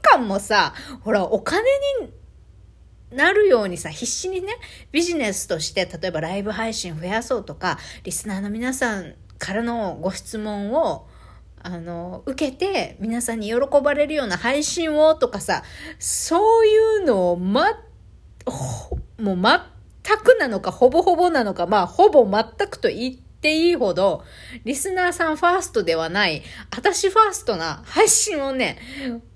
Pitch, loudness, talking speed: 265 Hz, -20 LUFS, 280 characters per minute